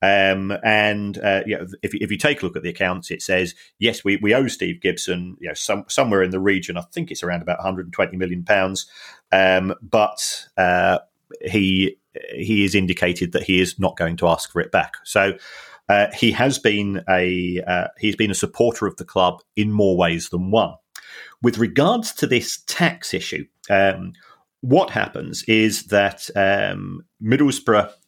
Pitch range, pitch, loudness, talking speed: 90-105 Hz, 100 Hz, -20 LUFS, 185 wpm